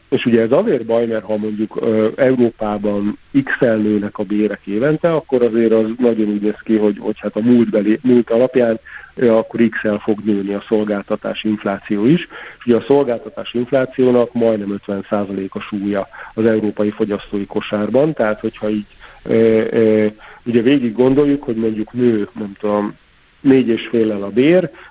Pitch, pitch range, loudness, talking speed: 110 Hz, 105-120 Hz, -16 LUFS, 160 wpm